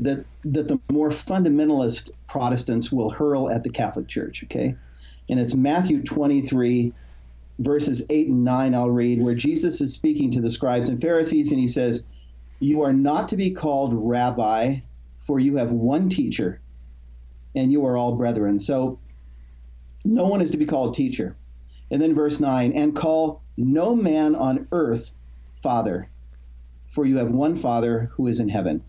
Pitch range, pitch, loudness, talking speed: 105-150 Hz, 125 Hz, -22 LUFS, 165 wpm